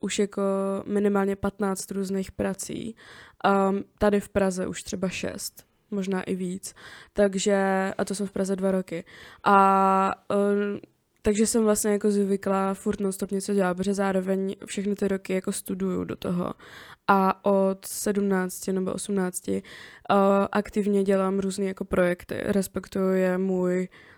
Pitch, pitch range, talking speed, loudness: 195 Hz, 190-200 Hz, 140 wpm, -26 LUFS